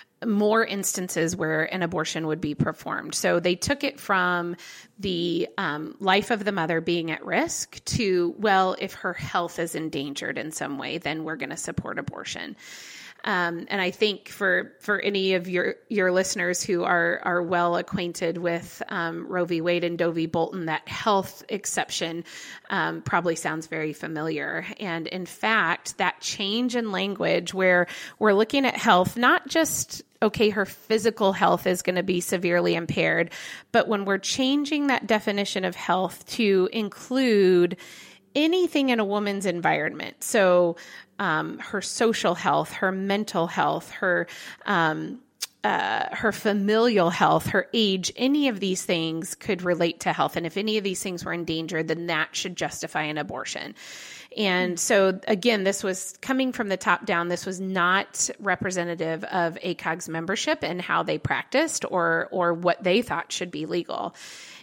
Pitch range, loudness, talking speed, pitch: 170-210 Hz, -25 LUFS, 165 wpm, 185 Hz